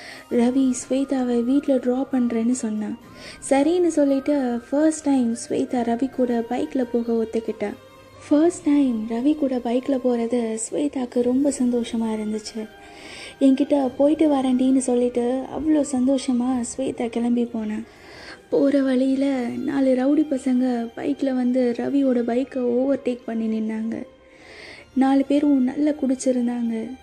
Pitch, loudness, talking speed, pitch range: 255 Hz, -22 LUFS, 115 wpm, 240-275 Hz